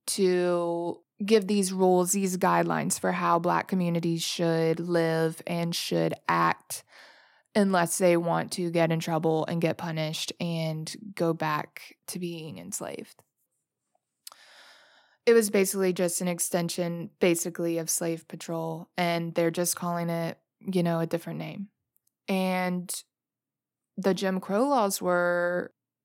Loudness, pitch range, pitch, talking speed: -27 LUFS, 165-185 Hz, 175 Hz, 130 wpm